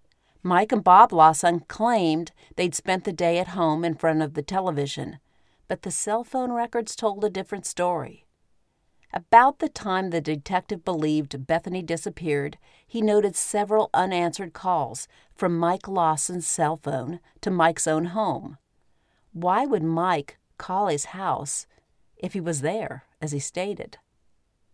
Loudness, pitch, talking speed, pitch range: -24 LUFS, 175 Hz, 145 wpm, 160-205 Hz